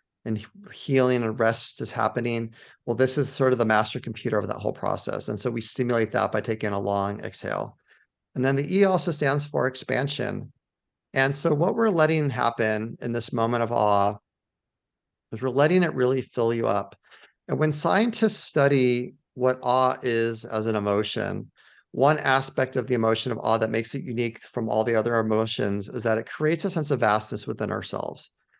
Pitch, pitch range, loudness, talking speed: 120 Hz, 110-135 Hz, -25 LUFS, 190 wpm